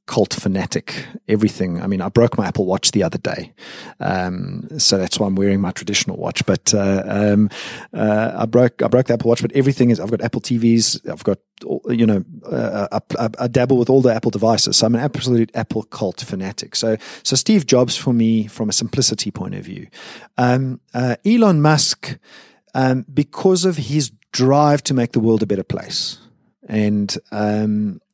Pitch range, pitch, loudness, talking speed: 105-130 Hz, 115 Hz, -18 LUFS, 190 wpm